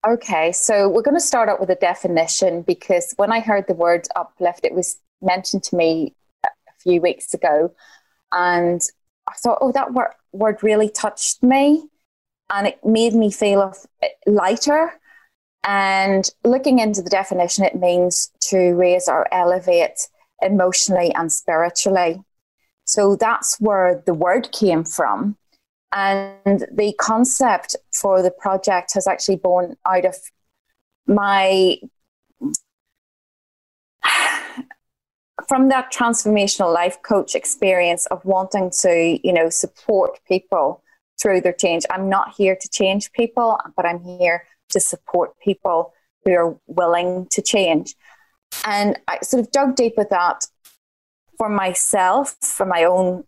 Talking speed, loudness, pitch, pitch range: 140 wpm, -18 LUFS, 195 Hz, 180-225 Hz